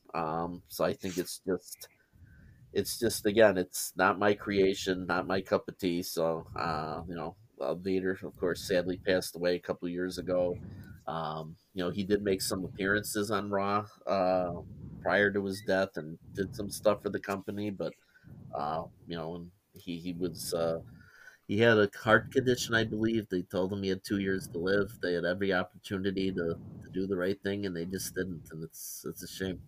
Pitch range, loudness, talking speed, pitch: 90-100 Hz, -32 LUFS, 200 wpm, 95 Hz